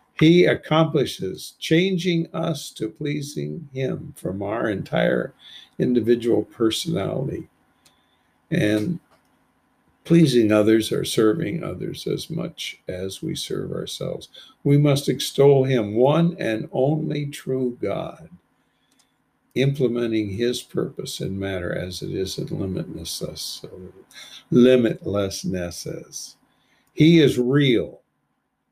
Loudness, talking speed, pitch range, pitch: -22 LUFS, 100 wpm, 110-155 Hz, 130 Hz